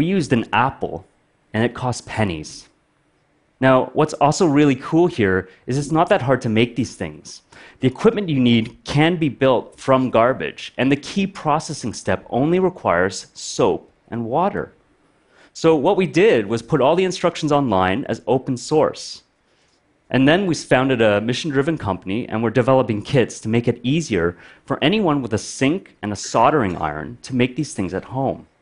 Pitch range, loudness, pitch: 115-155 Hz, -19 LUFS, 130 Hz